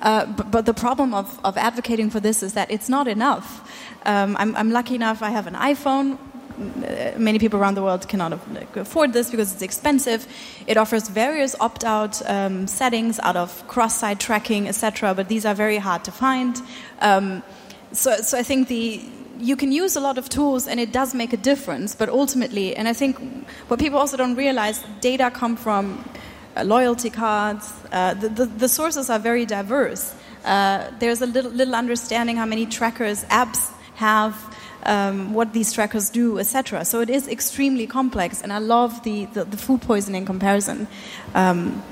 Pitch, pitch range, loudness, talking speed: 230 Hz, 210-255 Hz, -21 LUFS, 185 wpm